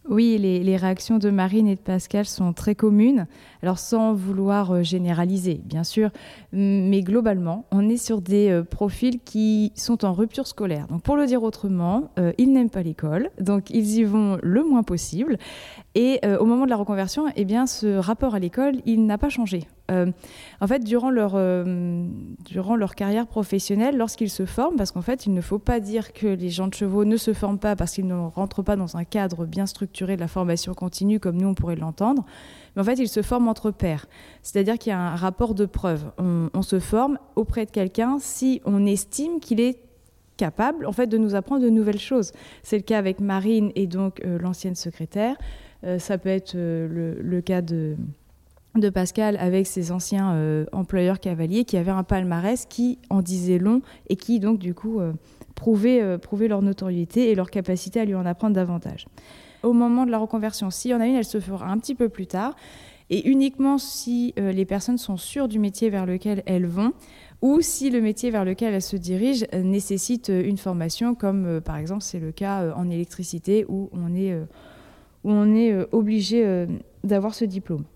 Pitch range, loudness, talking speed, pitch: 185-225 Hz, -23 LUFS, 210 wpm, 200 Hz